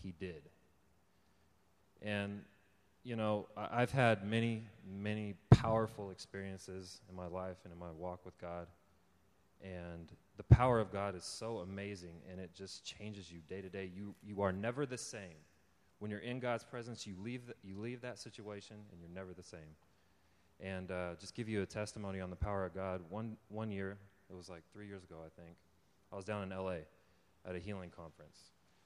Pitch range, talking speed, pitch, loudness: 90-105 Hz, 190 wpm, 95 Hz, -40 LUFS